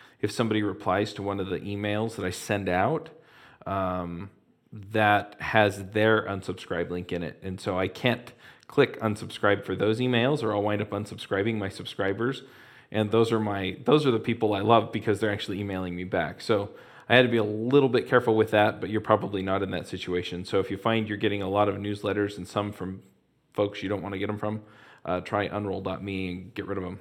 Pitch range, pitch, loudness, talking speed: 95-110 Hz, 105 Hz, -27 LUFS, 220 wpm